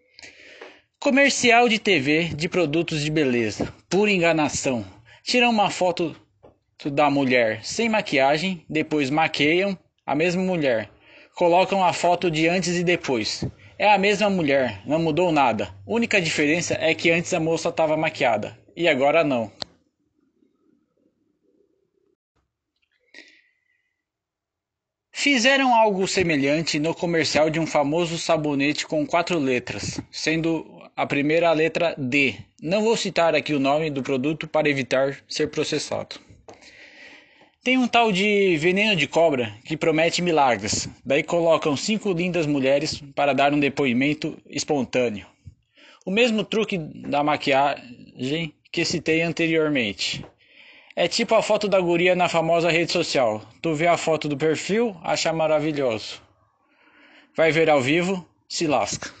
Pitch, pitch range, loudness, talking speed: 165 Hz, 150-195 Hz, -21 LUFS, 130 wpm